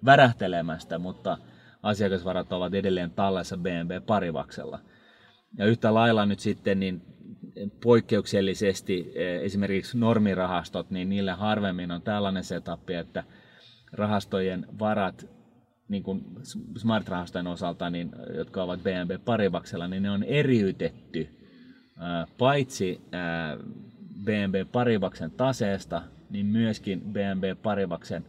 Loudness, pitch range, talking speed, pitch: -28 LUFS, 90-110 Hz, 100 wpm, 100 Hz